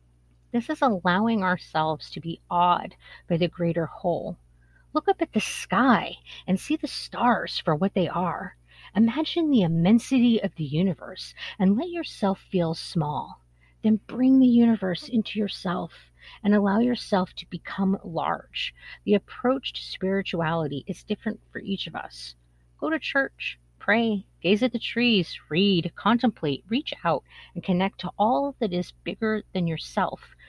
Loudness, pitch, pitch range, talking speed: -25 LUFS, 195 Hz, 170-230 Hz, 155 wpm